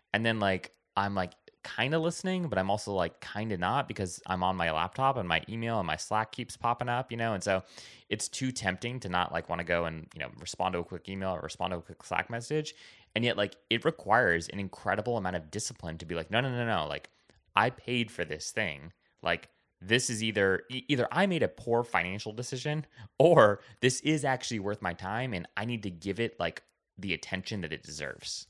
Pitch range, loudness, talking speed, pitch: 90-120 Hz, -31 LUFS, 235 wpm, 105 Hz